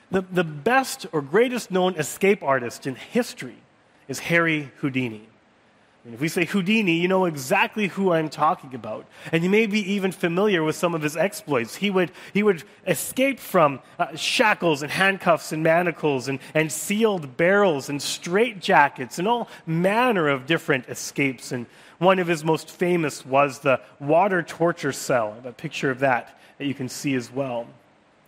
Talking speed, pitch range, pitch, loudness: 175 wpm, 140-190 Hz, 165 Hz, -23 LUFS